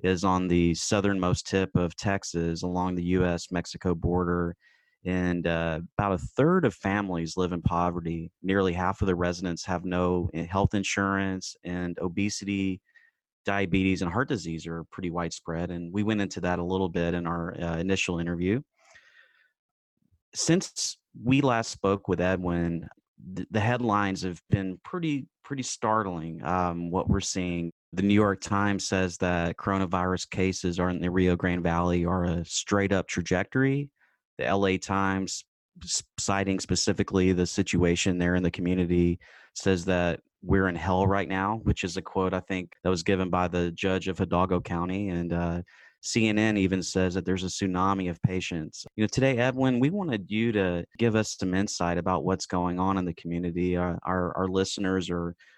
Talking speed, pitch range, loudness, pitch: 170 wpm, 90-100 Hz, -28 LUFS, 95 Hz